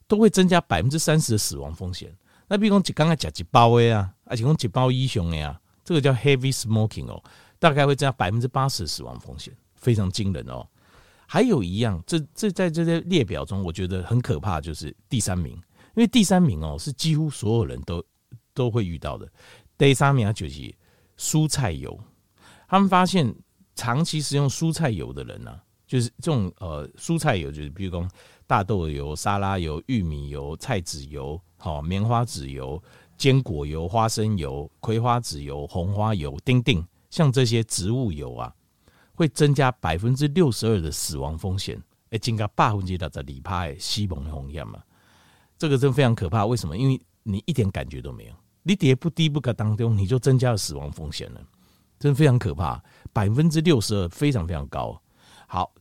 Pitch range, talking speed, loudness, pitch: 85-135 Hz, 290 characters per minute, -23 LUFS, 110 Hz